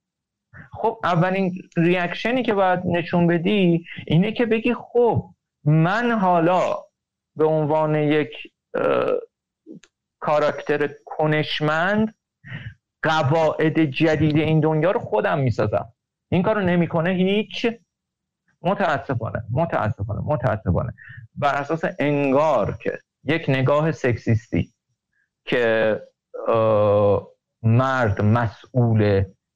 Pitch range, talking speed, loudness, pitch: 130-180 Hz, 85 wpm, -21 LUFS, 155 Hz